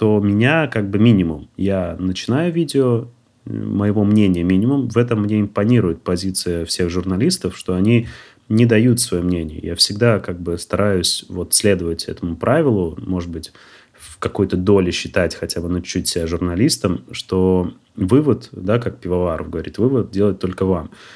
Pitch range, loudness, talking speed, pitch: 90-115 Hz, -18 LUFS, 160 wpm, 95 Hz